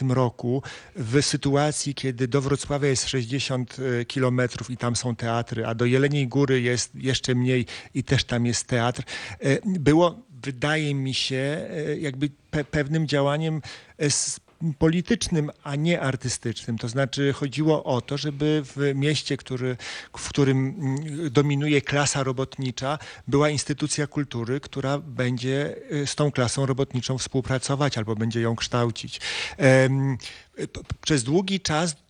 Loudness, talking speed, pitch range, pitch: -25 LUFS, 130 wpm, 125-145 Hz, 135 Hz